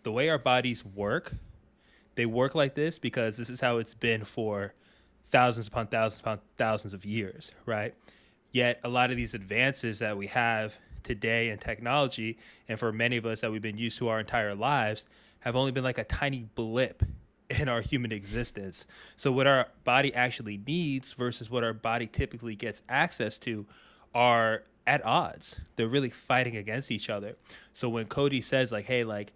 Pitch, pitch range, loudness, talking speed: 115 Hz, 110-125 Hz, -30 LUFS, 185 wpm